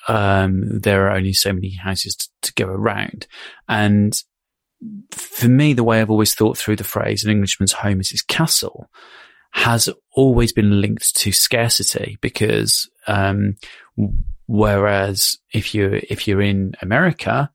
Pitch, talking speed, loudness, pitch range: 105 Hz, 145 wpm, -17 LUFS, 100-115 Hz